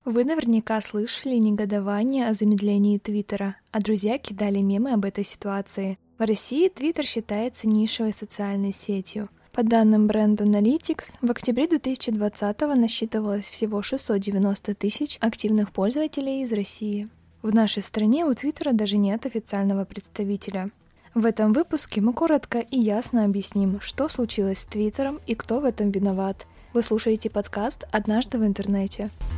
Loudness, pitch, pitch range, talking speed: -24 LUFS, 215 Hz, 205-240 Hz, 140 wpm